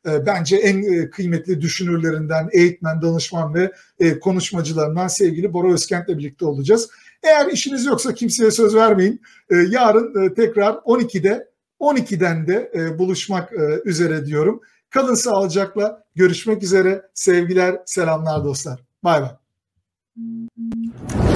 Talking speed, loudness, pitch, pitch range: 100 wpm, -18 LUFS, 185 Hz, 165-215 Hz